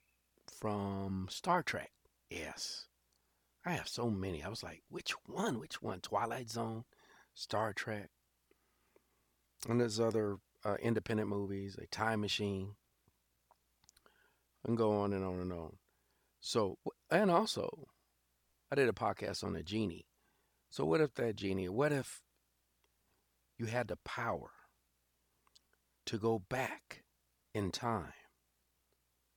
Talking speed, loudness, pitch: 125 wpm, -38 LUFS, 95 Hz